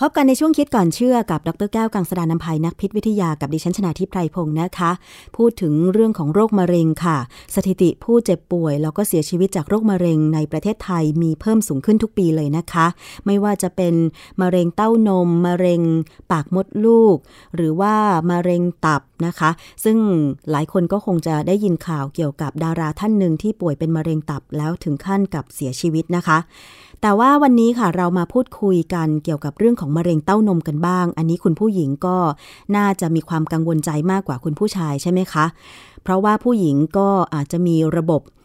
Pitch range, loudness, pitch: 160-200 Hz, -18 LUFS, 175 Hz